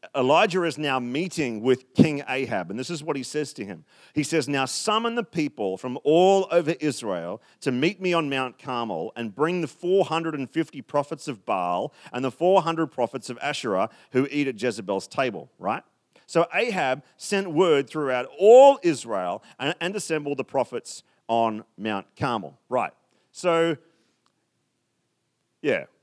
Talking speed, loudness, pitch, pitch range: 155 wpm, -24 LUFS, 150 Hz, 130-170 Hz